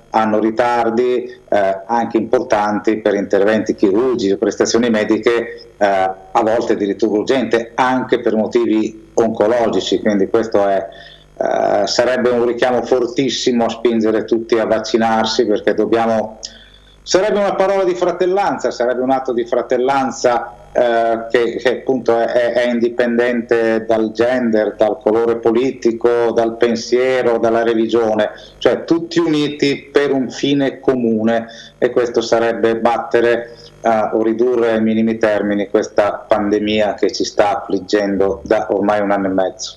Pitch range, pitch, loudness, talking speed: 110-120 Hz, 115 Hz, -16 LUFS, 135 wpm